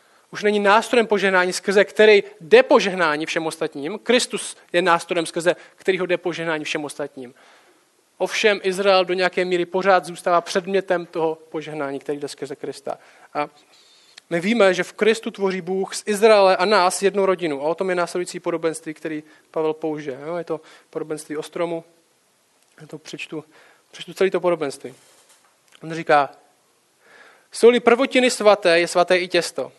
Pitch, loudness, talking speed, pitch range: 175 Hz, -20 LUFS, 150 wpm, 160-195 Hz